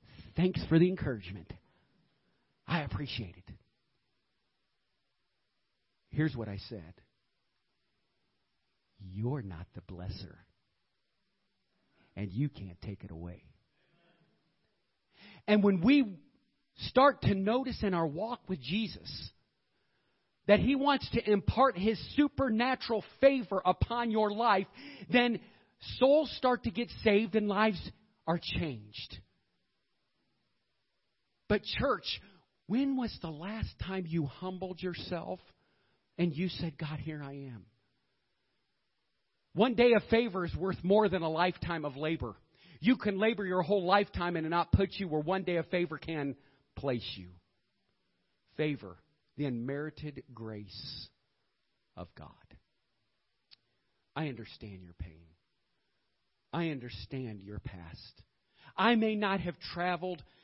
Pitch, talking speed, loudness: 165 Hz, 120 wpm, -32 LUFS